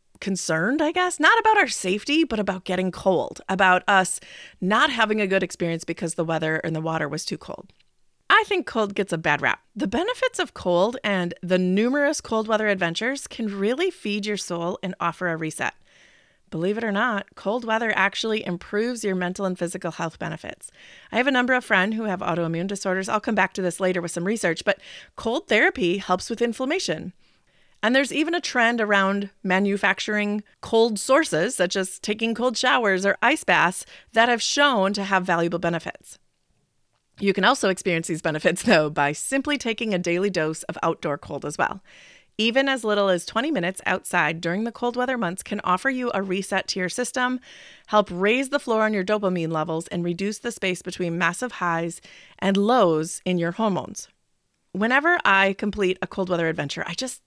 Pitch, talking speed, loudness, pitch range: 195 Hz, 190 wpm, -23 LUFS, 180-230 Hz